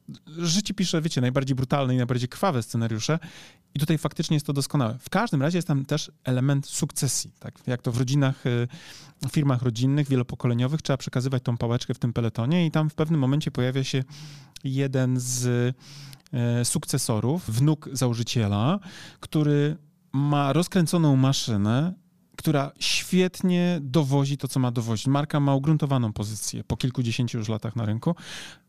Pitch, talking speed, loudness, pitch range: 140 Hz, 150 wpm, -25 LUFS, 125-155 Hz